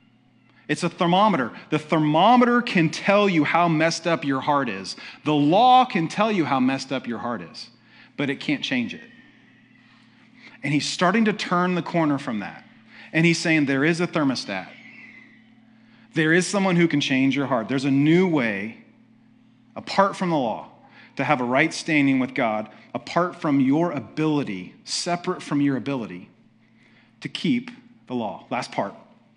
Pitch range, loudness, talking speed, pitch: 145-230 Hz, -22 LUFS, 170 wpm, 170 Hz